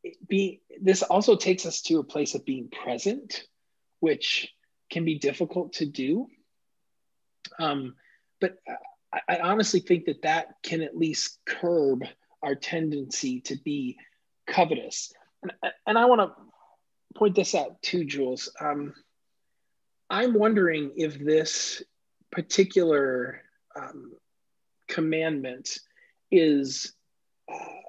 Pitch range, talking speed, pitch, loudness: 155-245 Hz, 115 wpm, 185 Hz, -26 LUFS